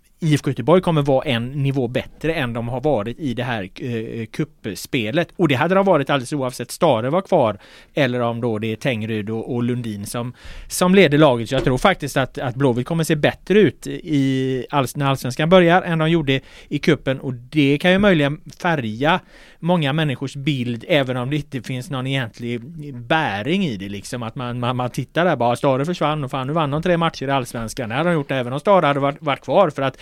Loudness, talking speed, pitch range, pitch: -20 LUFS, 220 wpm, 125-160 Hz, 140 Hz